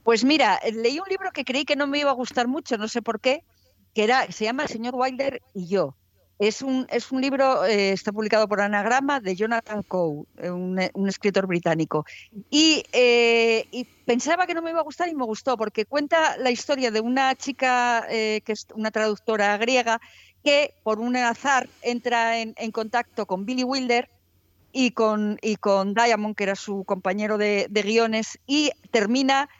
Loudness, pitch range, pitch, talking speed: -23 LUFS, 210-260 Hz, 230 Hz, 195 wpm